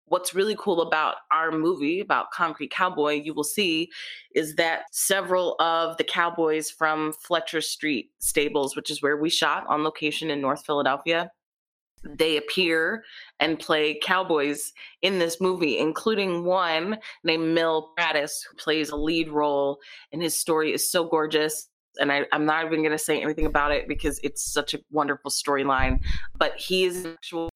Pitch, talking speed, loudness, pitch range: 155 Hz, 170 wpm, -25 LUFS, 150-170 Hz